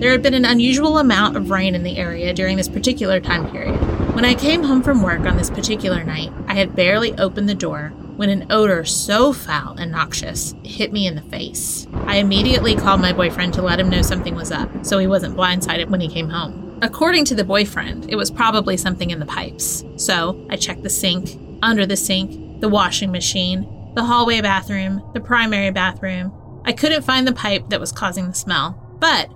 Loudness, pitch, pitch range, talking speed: -18 LUFS, 195 Hz, 185-230 Hz, 210 wpm